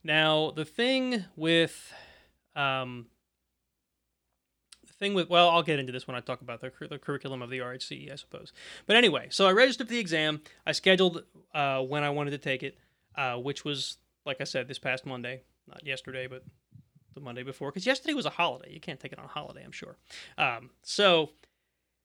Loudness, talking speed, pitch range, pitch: -28 LUFS, 200 wpm, 125-165 Hz, 140 Hz